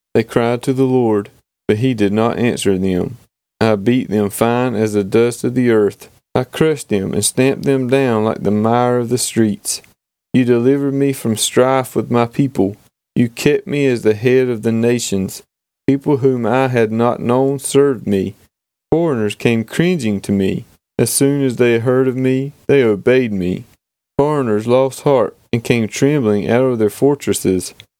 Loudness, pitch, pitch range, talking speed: -16 LUFS, 120 Hz, 105-130 Hz, 180 wpm